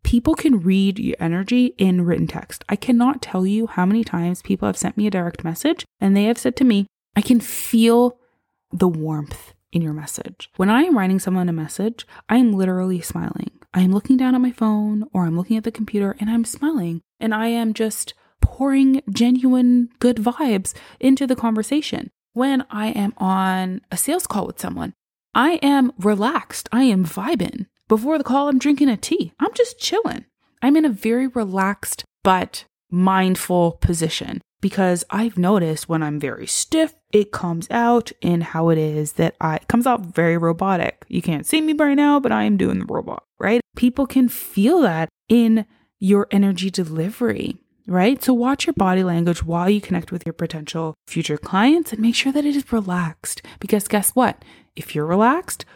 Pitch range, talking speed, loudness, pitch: 180-250 Hz, 190 wpm, -19 LUFS, 215 Hz